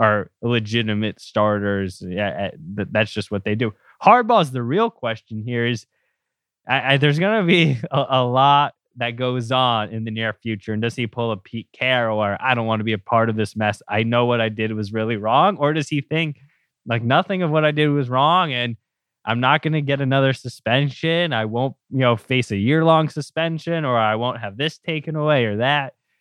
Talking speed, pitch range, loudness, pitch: 215 wpm, 110-145 Hz, -20 LUFS, 120 Hz